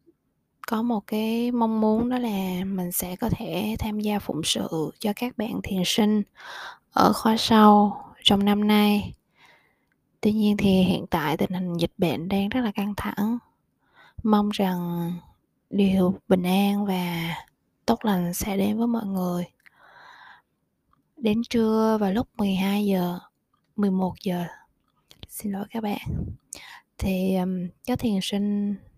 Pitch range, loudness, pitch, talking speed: 185-220 Hz, -24 LUFS, 205 Hz, 145 wpm